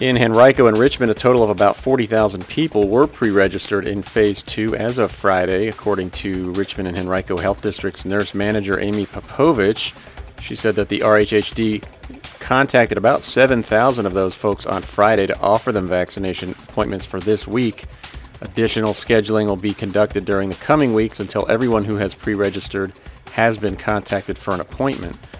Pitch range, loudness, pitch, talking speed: 95-110 Hz, -18 LUFS, 105 Hz, 165 wpm